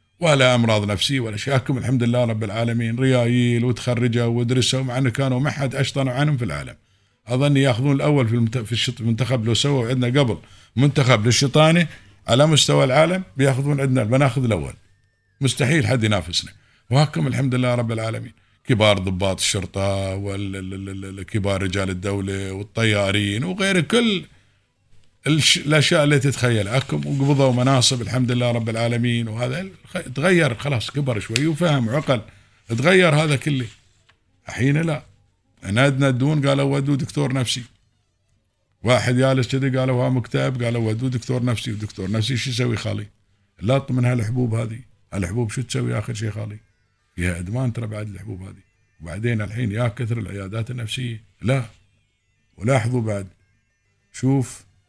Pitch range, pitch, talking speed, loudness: 105-135 Hz, 120 Hz, 140 wpm, -20 LUFS